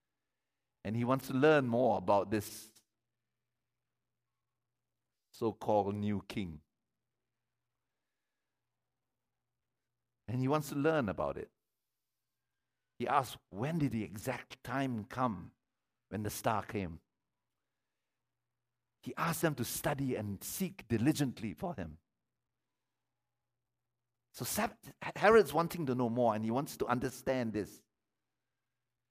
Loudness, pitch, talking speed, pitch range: -34 LUFS, 120 Hz, 110 wpm, 110-130 Hz